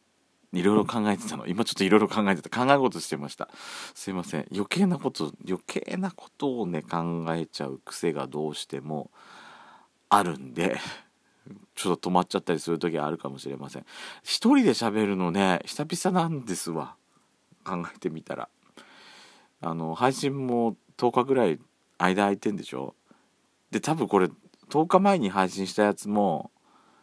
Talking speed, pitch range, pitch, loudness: 310 characters per minute, 80-125 Hz, 95 Hz, -27 LUFS